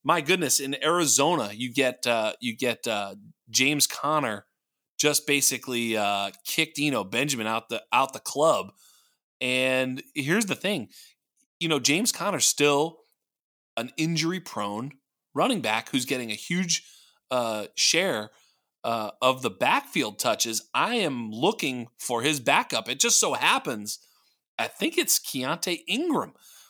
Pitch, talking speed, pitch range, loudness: 135 Hz, 145 wpm, 120-160 Hz, -25 LUFS